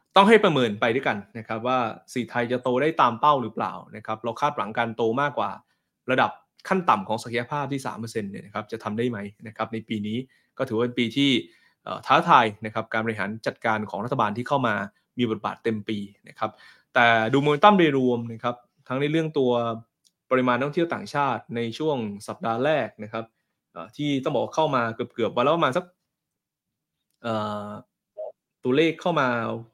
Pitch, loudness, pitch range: 120 Hz, -24 LUFS, 110-140 Hz